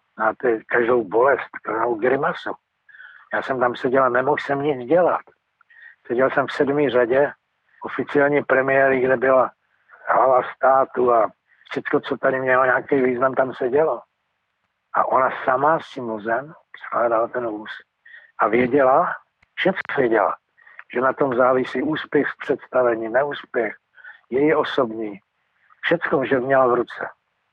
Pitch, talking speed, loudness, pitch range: 130 Hz, 135 wpm, -20 LUFS, 125-140 Hz